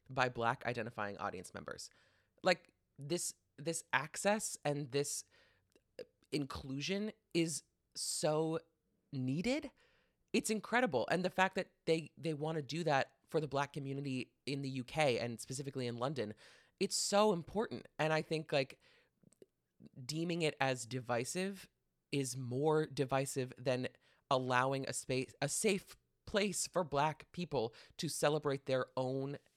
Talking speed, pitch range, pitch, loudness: 135 wpm, 130-170 Hz, 145 Hz, -38 LUFS